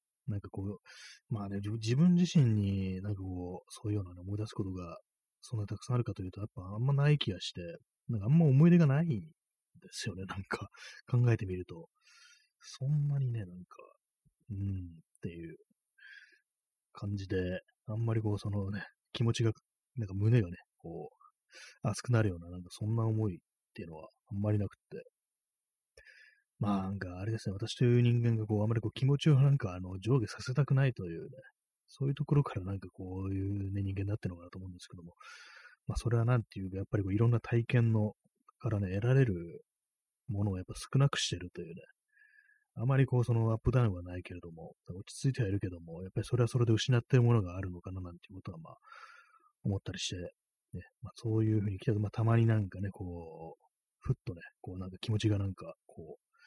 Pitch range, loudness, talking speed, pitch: 95-125 Hz, -33 LUFS, 410 characters per minute, 110 Hz